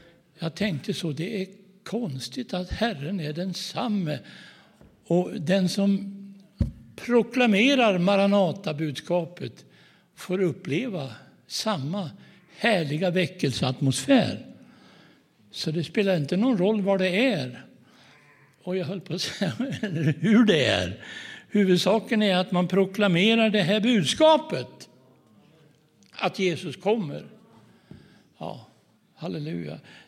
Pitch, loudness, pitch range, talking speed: 190 Hz, -25 LUFS, 165-210 Hz, 100 wpm